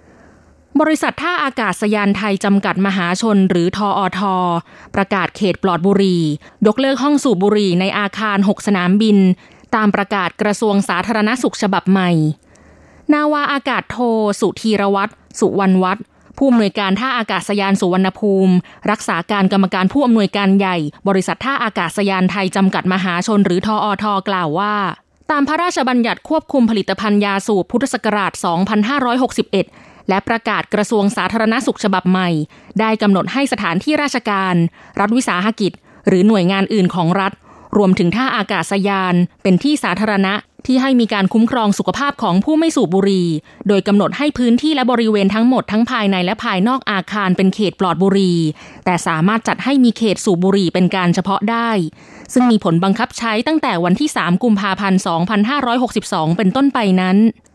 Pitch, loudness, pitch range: 200 Hz, -15 LUFS, 185-225 Hz